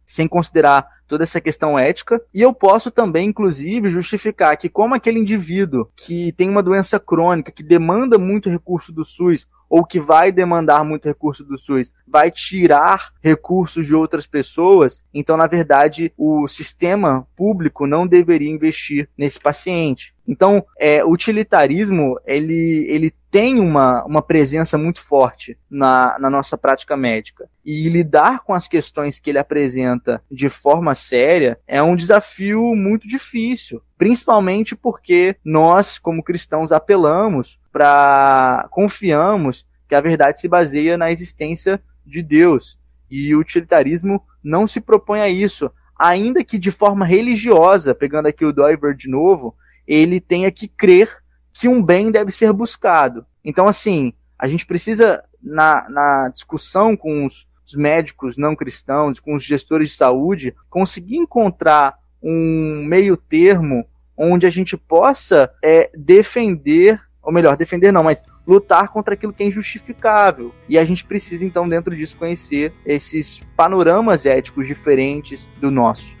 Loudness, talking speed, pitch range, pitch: -15 LUFS, 145 wpm, 145-200 Hz, 165 Hz